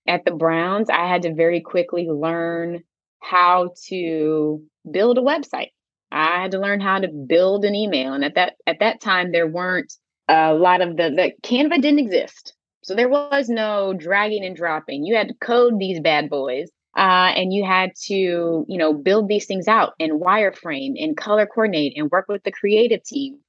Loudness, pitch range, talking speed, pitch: -19 LUFS, 170-215 Hz, 190 wpm, 185 Hz